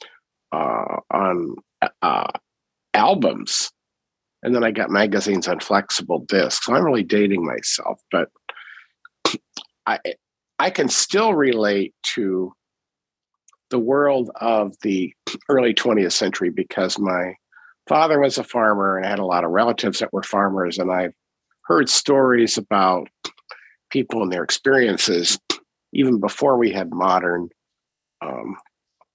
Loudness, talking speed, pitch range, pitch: -20 LUFS, 130 wpm, 95-135 Hz, 105 Hz